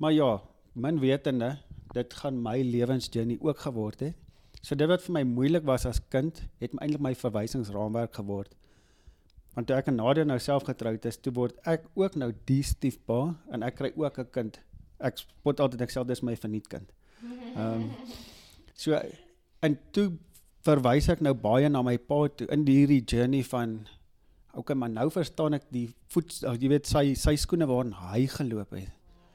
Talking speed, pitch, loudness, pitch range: 180 wpm, 130 Hz, -29 LUFS, 115-145 Hz